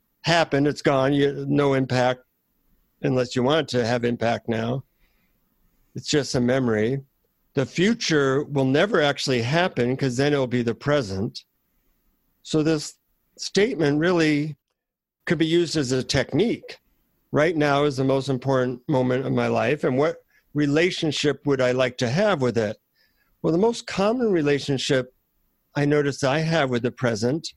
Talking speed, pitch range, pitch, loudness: 155 wpm, 125-155 Hz, 140 Hz, -23 LUFS